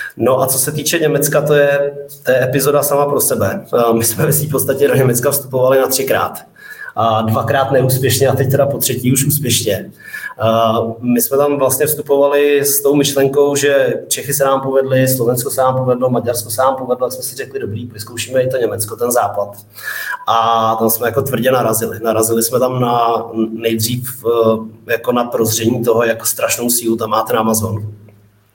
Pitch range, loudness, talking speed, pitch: 115-140 Hz, -14 LUFS, 185 wpm, 125 Hz